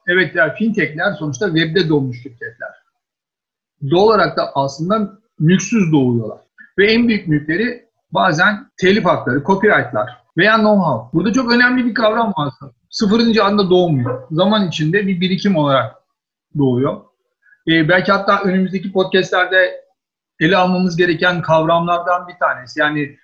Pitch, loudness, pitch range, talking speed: 185 Hz, -15 LUFS, 155-215 Hz, 135 wpm